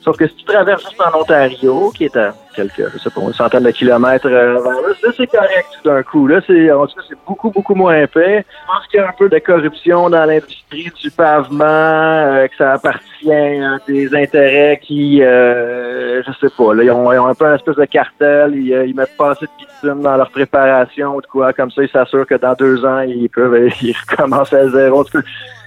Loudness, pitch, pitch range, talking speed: -12 LUFS, 145 Hz, 130-160 Hz, 235 wpm